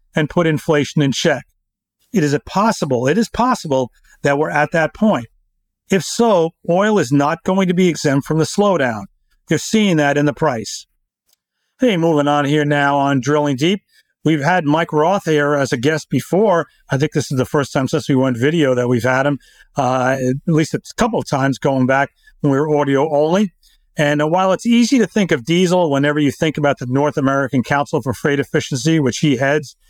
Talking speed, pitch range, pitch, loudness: 205 wpm, 140-170 Hz, 150 Hz, -16 LUFS